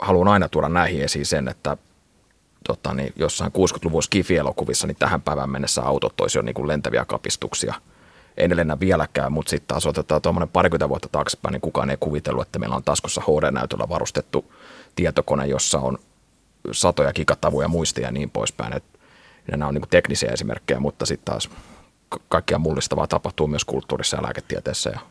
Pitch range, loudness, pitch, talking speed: 70-85 Hz, -22 LUFS, 75 Hz, 160 wpm